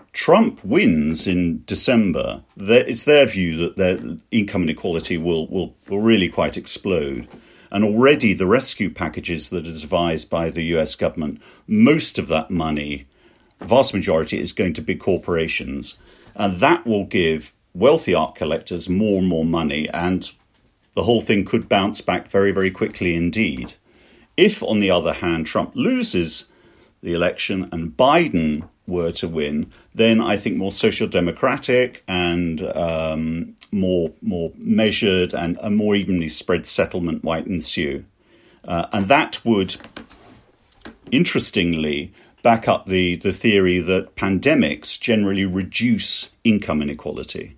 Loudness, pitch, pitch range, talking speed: -20 LUFS, 90 Hz, 85-100 Hz, 140 wpm